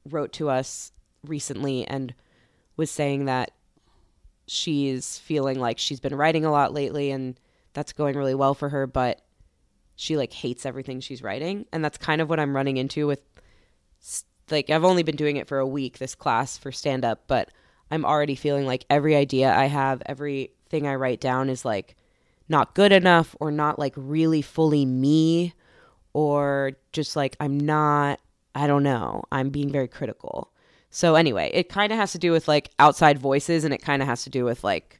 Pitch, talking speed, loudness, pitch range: 140 Hz, 190 wpm, -24 LUFS, 135-150 Hz